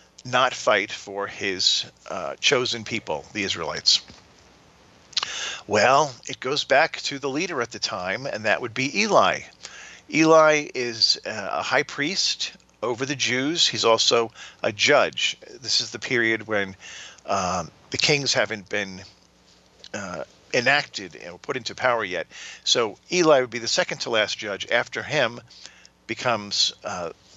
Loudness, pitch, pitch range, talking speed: -22 LUFS, 115 Hz, 105-135 Hz, 145 wpm